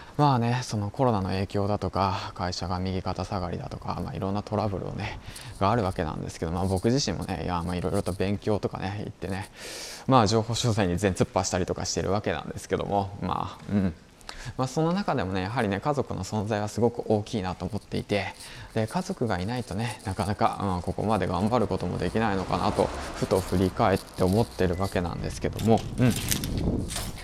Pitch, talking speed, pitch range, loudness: 100 Hz, 420 characters per minute, 95-115 Hz, -28 LUFS